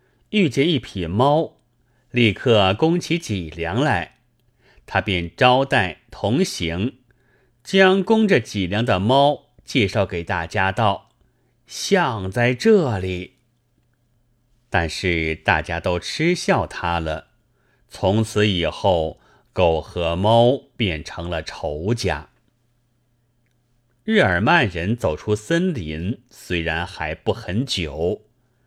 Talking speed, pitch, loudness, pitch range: 145 characters per minute, 115 Hz, -20 LUFS, 95-125 Hz